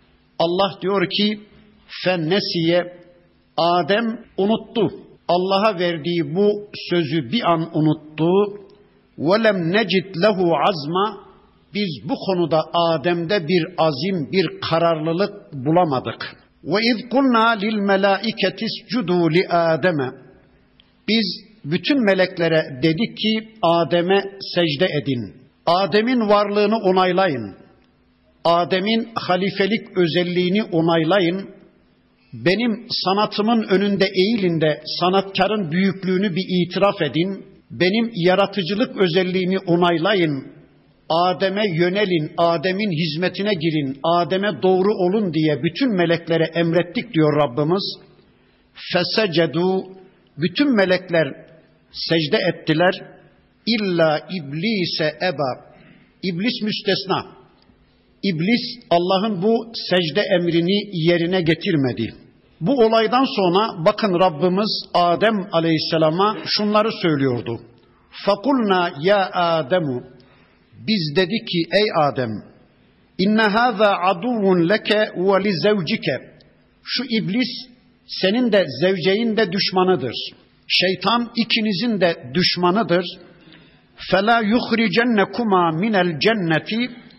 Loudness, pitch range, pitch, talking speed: -19 LUFS, 170-210 Hz, 185 Hz, 90 wpm